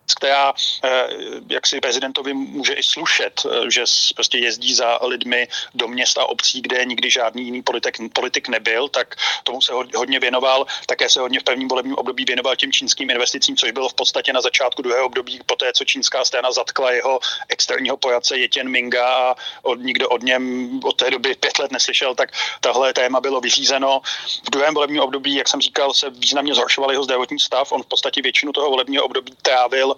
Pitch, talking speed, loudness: 135 Hz, 195 wpm, -17 LUFS